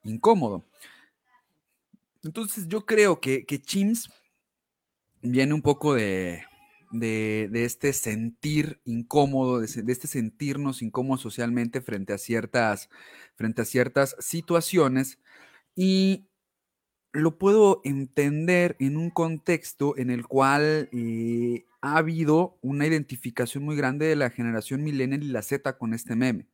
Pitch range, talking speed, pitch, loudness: 120-160 Hz, 125 wpm, 140 Hz, -26 LUFS